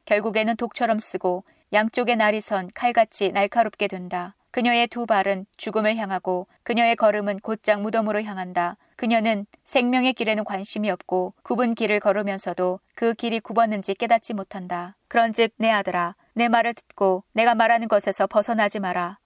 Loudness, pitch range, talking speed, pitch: -23 LUFS, 195-230 Hz, 350 characters per minute, 215 Hz